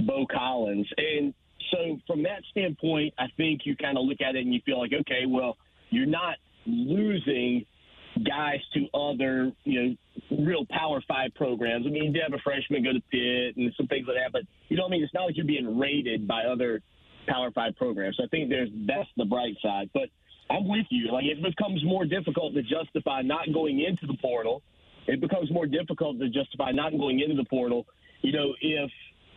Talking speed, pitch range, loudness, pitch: 210 wpm, 125-160 Hz, -28 LUFS, 145 Hz